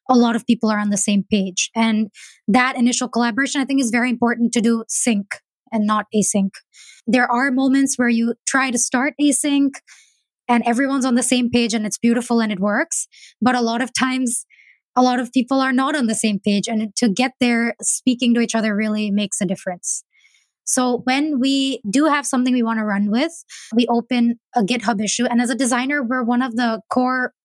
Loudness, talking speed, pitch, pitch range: -19 LUFS, 210 wpm, 240 Hz, 225-260 Hz